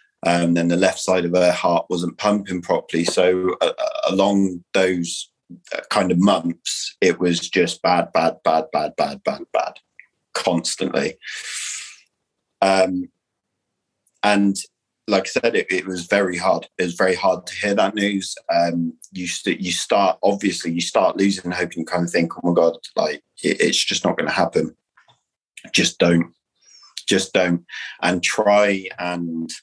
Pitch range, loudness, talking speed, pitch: 85-95 Hz, -20 LUFS, 160 wpm, 90 Hz